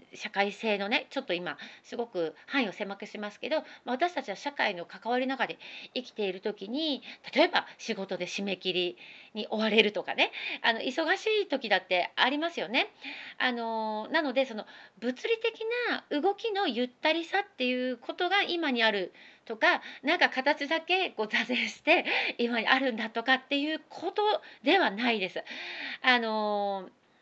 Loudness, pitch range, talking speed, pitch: -29 LUFS, 215-310 Hz, 315 characters per minute, 250 Hz